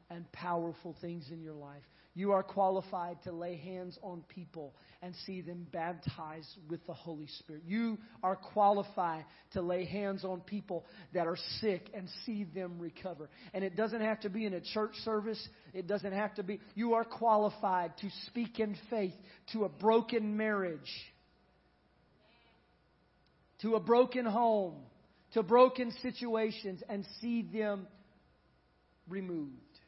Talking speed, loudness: 150 wpm, -36 LUFS